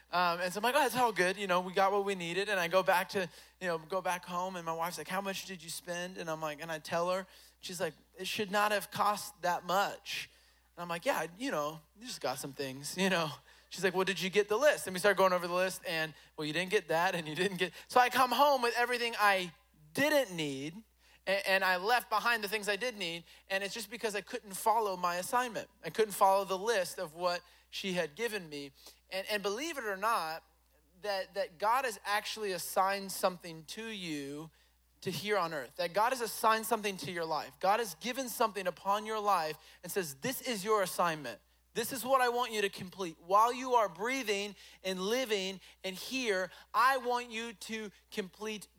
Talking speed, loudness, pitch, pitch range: 230 wpm, -33 LUFS, 195 Hz, 175-220 Hz